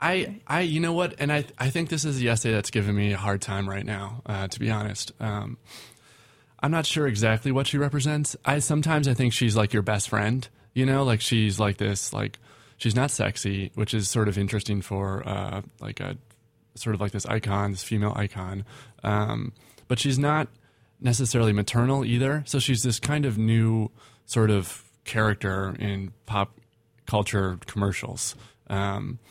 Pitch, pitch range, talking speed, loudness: 115 Hz, 105-130 Hz, 200 wpm, -26 LUFS